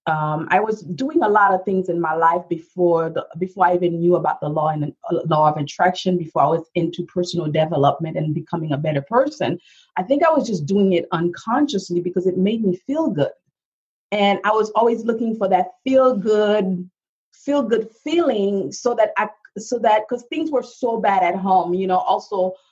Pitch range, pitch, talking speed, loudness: 170-220 Hz, 185 Hz, 205 wpm, -20 LUFS